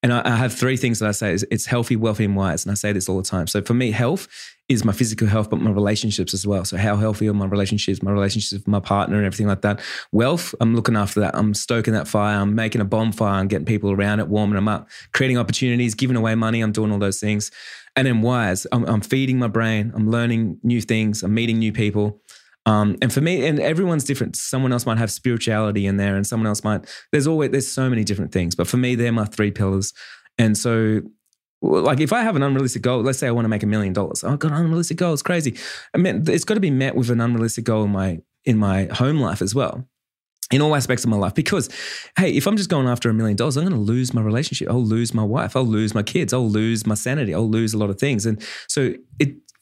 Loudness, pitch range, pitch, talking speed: -20 LUFS, 105-125 Hz, 110 Hz, 260 wpm